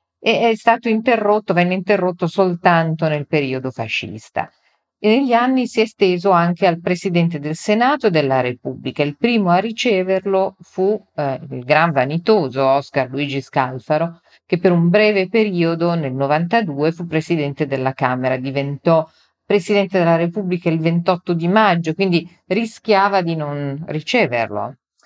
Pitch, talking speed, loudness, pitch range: 170 Hz, 140 wpm, -18 LUFS, 145-195 Hz